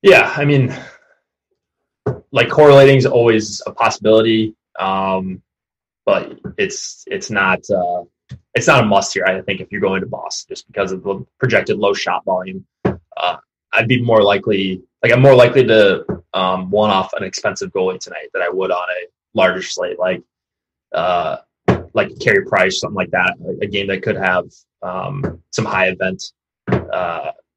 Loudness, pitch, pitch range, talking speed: -16 LUFS, 110 Hz, 95-140 Hz, 165 wpm